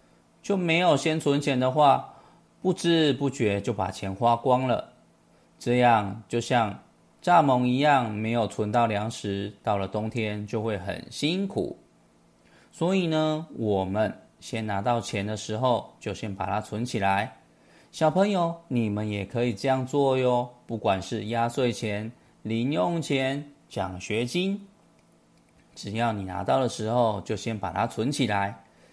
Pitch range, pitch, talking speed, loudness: 105-140 Hz, 120 Hz, 205 characters per minute, -26 LUFS